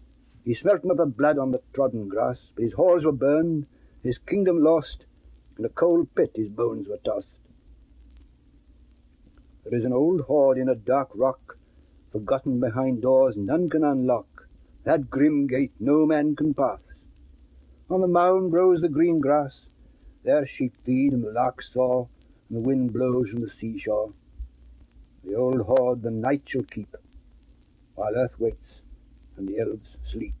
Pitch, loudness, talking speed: 125 Hz, -24 LUFS, 160 wpm